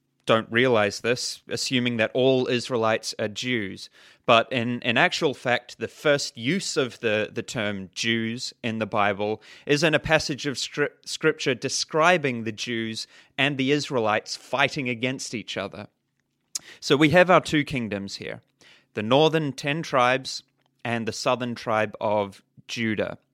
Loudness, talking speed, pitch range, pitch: -24 LUFS, 150 wpm, 115-140 Hz, 125 Hz